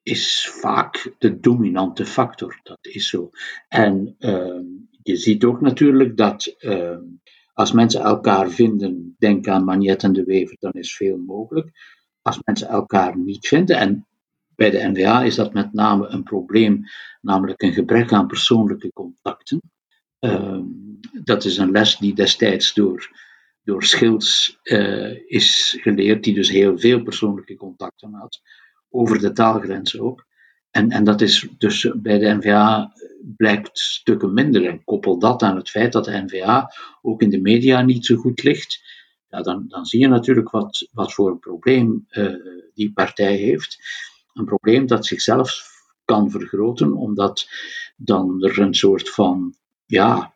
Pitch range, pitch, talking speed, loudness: 100-125 Hz, 110 Hz, 155 wpm, -18 LUFS